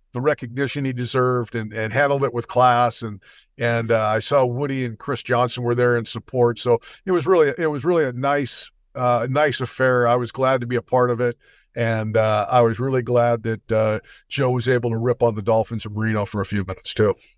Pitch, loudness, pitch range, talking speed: 120 Hz, -21 LUFS, 115-130 Hz, 235 wpm